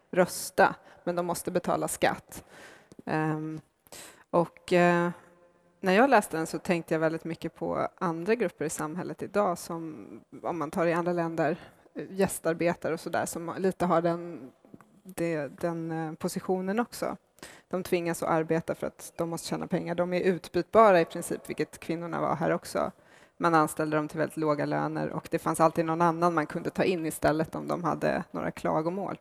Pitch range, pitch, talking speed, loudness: 160-175 Hz, 170 Hz, 170 wpm, -29 LUFS